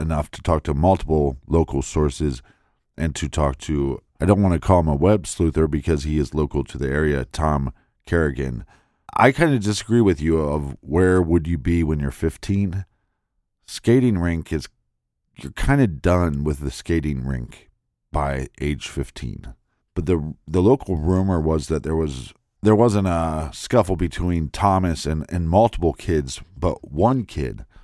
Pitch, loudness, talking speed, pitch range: 80 Hz, -21 LUFS, 170 wpm, 75-95 Hz